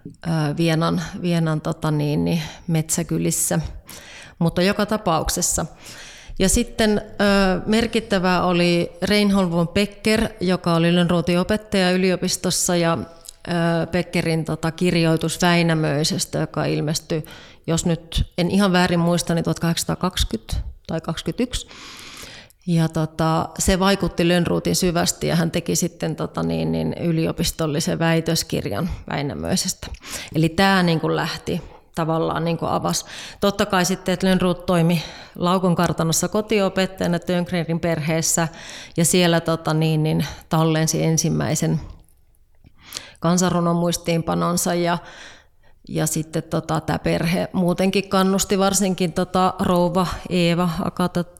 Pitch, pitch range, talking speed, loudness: 170 Hz, 160-185 Hz, 110 wpm, -21 LUFS